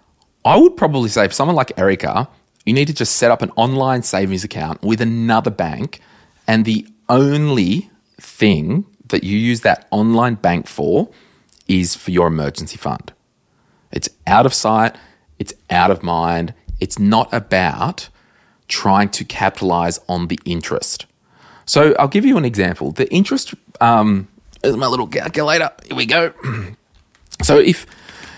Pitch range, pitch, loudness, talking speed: 95-120 Hz, 110 Hz, -16 LUFS, 150 wpm